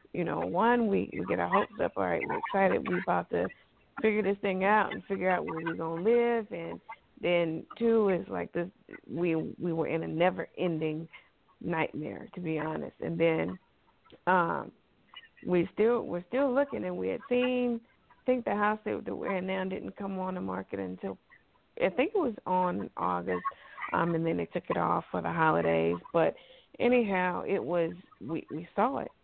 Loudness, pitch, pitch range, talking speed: -31 LUFS, 185 Hz, 165-225 Hz, 195 wpm